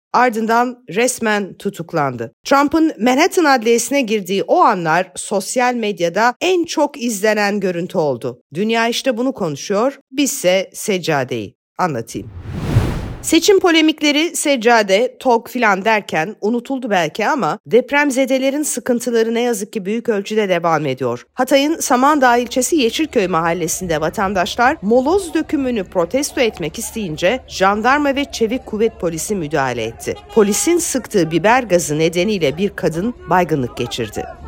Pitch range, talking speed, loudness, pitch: 180-265 Hz, 120 wpm, -16 LUFS, 225 Hz